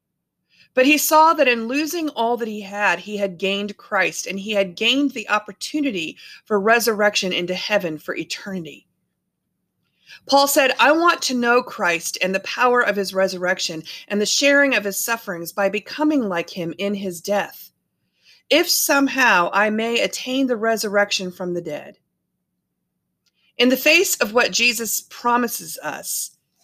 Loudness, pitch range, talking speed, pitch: -19 LUFS, 195-260 Hz, 160 wpm, 215 Hz